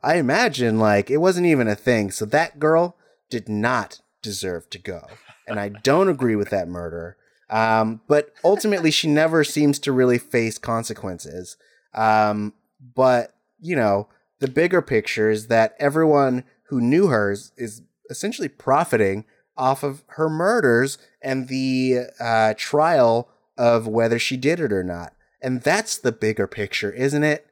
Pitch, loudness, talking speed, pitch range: 120 Hz, -20 LUFS, 155 wpm, 110-145 Hz